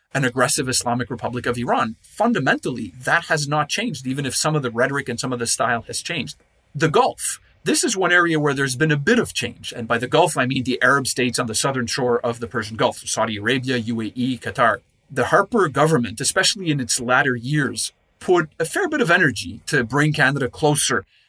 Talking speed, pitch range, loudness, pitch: 215 wpm, 120-150 Hz, -20 LUFS, 130 Hz